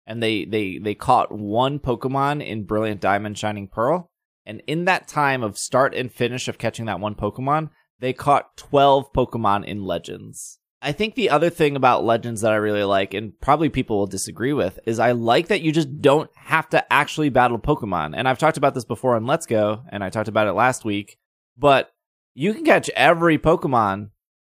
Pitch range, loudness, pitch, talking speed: 105-145 Hz, -21 LUFS, 120 Hz, 200 wpm